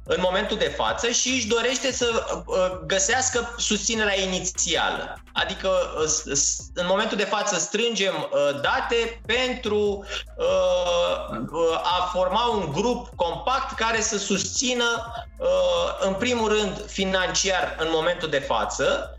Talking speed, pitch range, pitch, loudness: 110 wpm, 185-245 Hz, 215 Hz, -23 LUFS